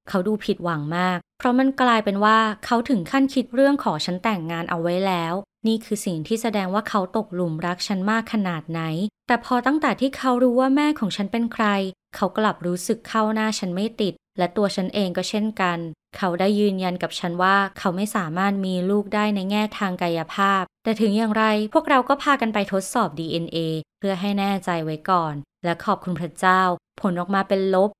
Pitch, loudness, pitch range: 200 Hz, -22 LUFS, 180-220 Hz